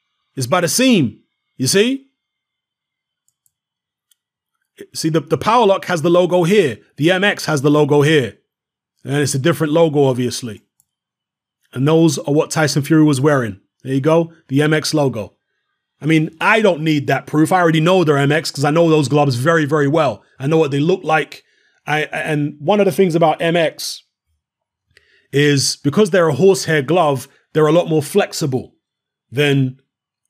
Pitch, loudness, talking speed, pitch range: 155 Hz, -15 LUFS, 170 wpm, 140-170 Hz